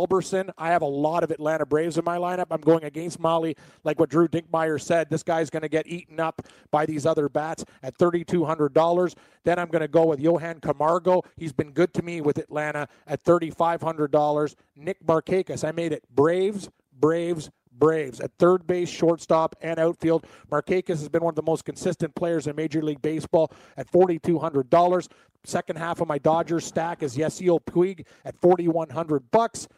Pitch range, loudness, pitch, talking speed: 155-170 Hz, -24 LUFS, 165 Hz, 180 wpm